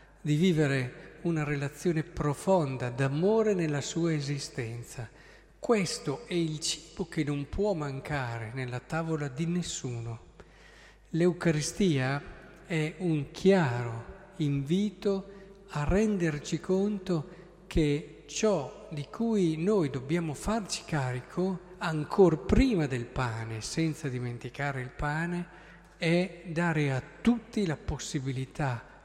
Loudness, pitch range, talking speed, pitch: -30 LUFS, 140-185 Hz, 105 wpm, 160 Hz